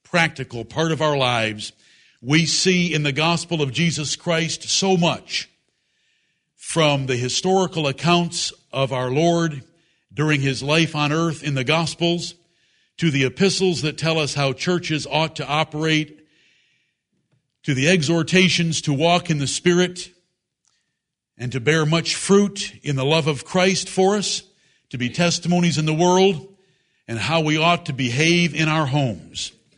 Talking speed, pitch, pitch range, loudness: 155 wpm, 160 Hz, 145-175 Hz, -20 LUFS